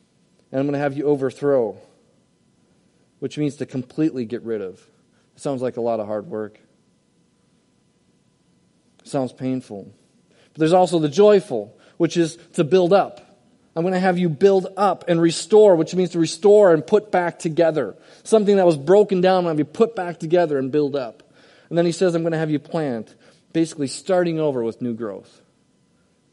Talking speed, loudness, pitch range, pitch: 185 wpm, -20 LUFS, 135-185 Hz, 165 Hz